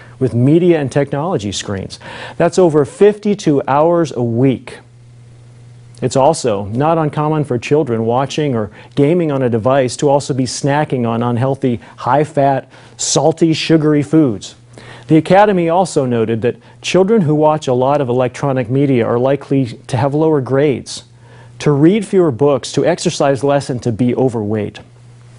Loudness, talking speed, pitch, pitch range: -14 LUFS, 150 wpm, 135 Hz, 120-155 Hz